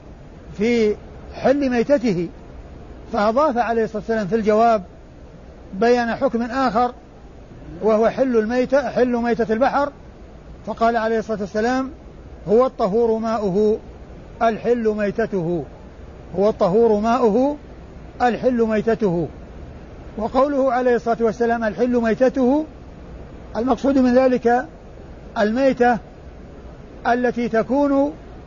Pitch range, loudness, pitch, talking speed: 215-245 Hz, -19 LUFS, 230 Hz, 95 wpm